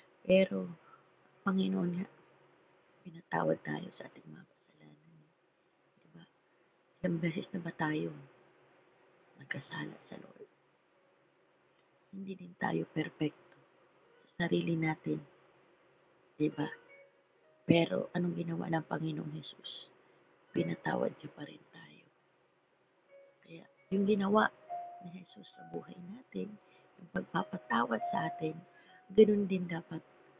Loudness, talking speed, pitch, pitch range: -35 LUFS, 105 wpm, 180 Hz, 160-190 Hz